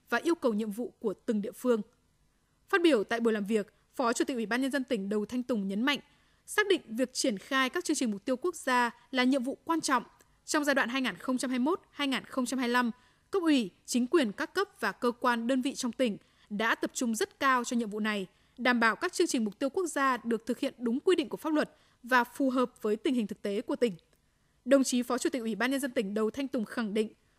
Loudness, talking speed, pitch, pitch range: -30 LUFS, 250 wpm, 250 Hz, 230-280 Hz